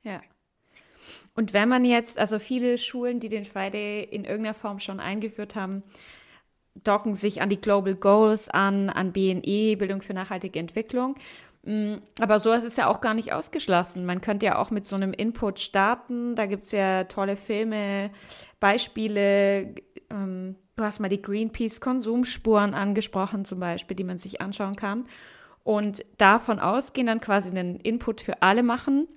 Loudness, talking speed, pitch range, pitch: -25 LUFS, 160 wpm, 195-225 Hz, 210 Hz